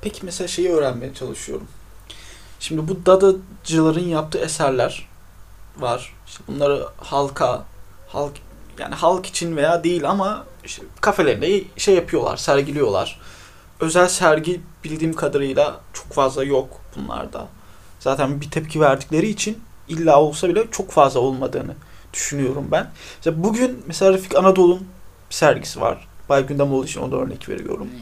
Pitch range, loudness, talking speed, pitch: 135-180 Hz, -20 LUFS, 135 wpm, 155 Hz